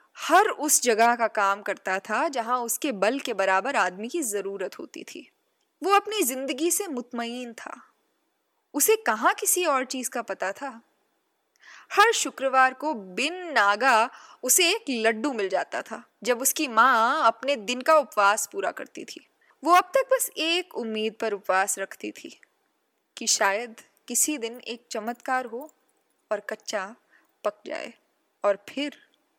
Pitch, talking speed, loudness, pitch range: 255 Hz, 155 wpm, -24 LUFS, 220-320 Hz